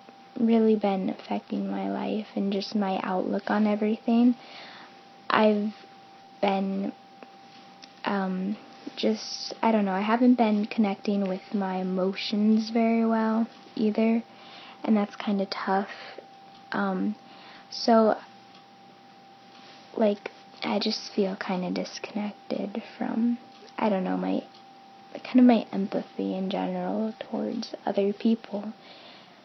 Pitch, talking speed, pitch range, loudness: 215 Hz, 115 wpm, 195-235 Hz, -27 LUFS